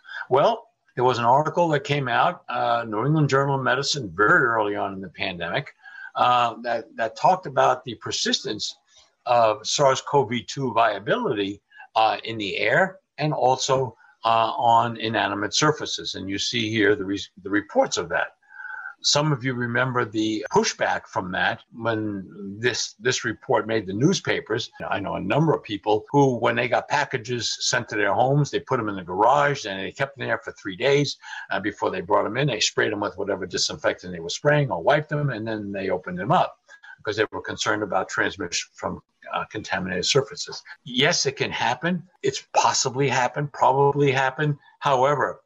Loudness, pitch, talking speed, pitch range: -23 LUFS, 130 Hz, 185 wpm, 110-145 Hz